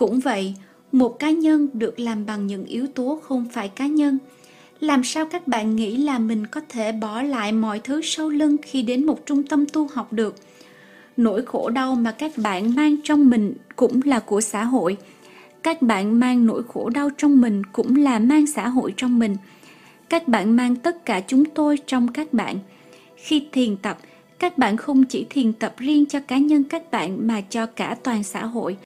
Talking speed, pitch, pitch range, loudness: 205 wpm, 250 Hz, 220-285 Hz, -21 LUFS